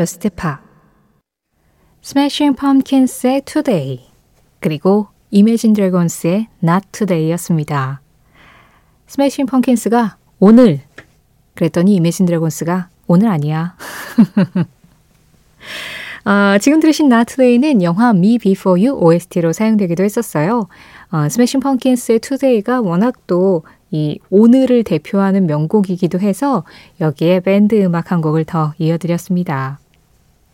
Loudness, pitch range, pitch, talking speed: -14 LUFS, 165-235 Hz, 195 Hz, 265 characters per minute